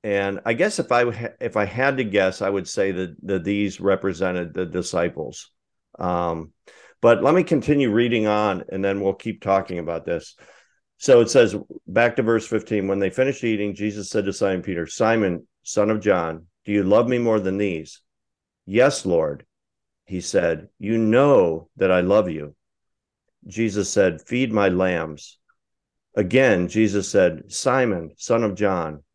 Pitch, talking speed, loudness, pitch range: 100 Hz, 170 wpm, -21 LUFS, 95-115 Hz